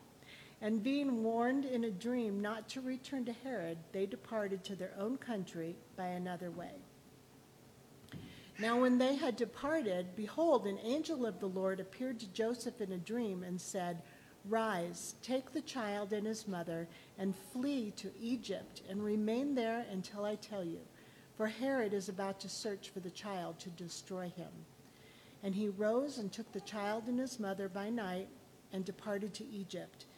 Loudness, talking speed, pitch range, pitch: -39 LUFS, 170 wpm, 190-235 Hz, 205 Hz